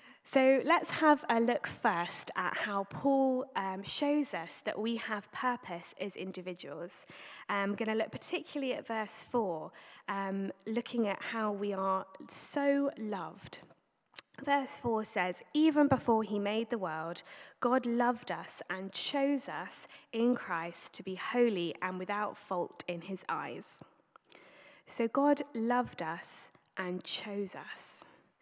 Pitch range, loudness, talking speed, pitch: 190-255 Hz, -34 LUFS, 140 wpm, 220 Hz